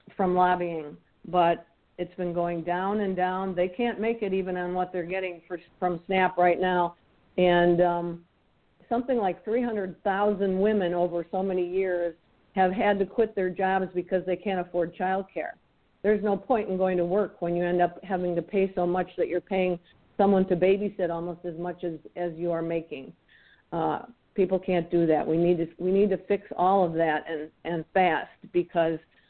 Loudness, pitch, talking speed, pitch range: -27 LUFS, 180 Hz, 190 wpm, 175-190 Hz